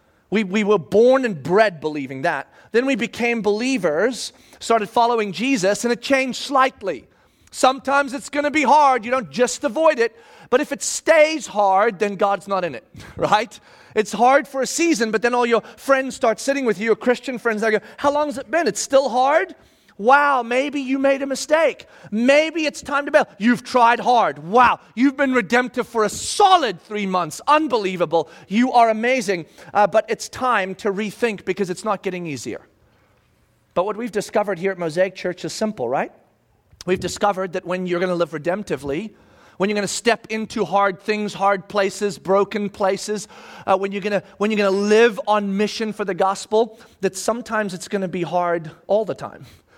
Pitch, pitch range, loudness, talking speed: 220 Hz, 195-260 Hz, -20 LUFS, 190 wpm